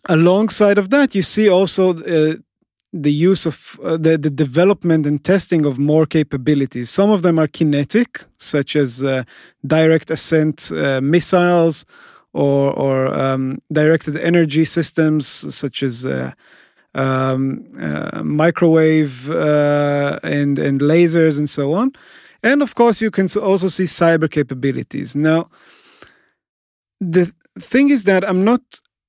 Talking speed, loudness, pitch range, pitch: 135 wpm, -16 LUFS, 145-185 Hz, 160 Hz